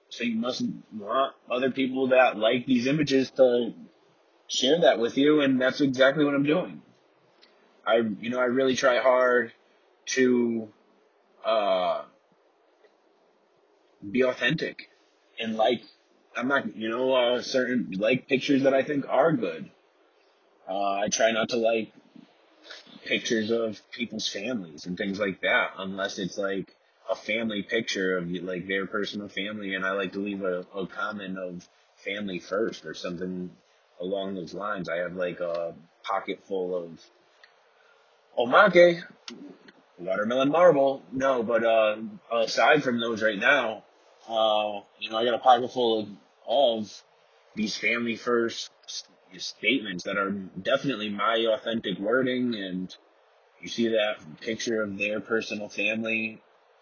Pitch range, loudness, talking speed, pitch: 100-130 Hz, -26 LUFS, 145 wpm, 115 Hz